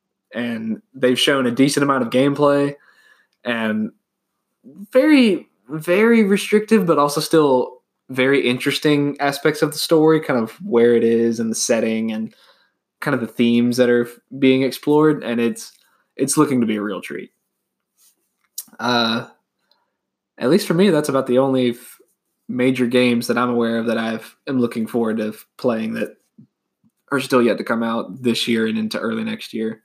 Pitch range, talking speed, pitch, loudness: 115-155 Hz, 165 wpm, 130 Hz, -18 LUFS